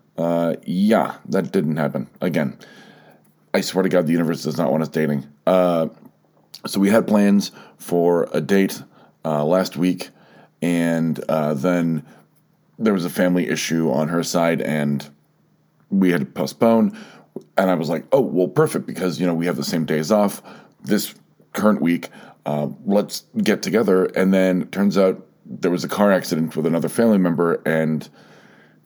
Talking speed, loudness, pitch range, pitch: 170 wpm, -20 LUFS, 80-95 Hz, 85 Hz